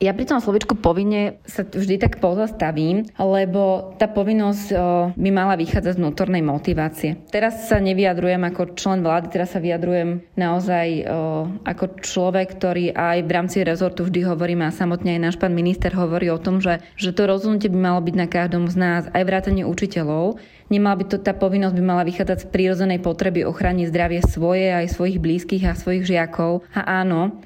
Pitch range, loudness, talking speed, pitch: 175-195 Hz, -20 LUFS, 185 wpm, 180 Hz